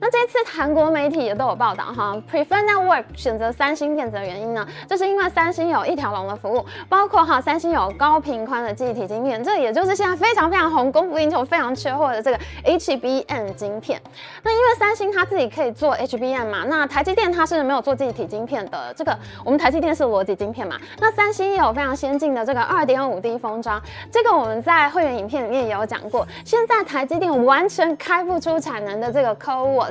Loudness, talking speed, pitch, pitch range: -20 LUFS, 380 characters per minute, 295 Hz, 250-360 Hz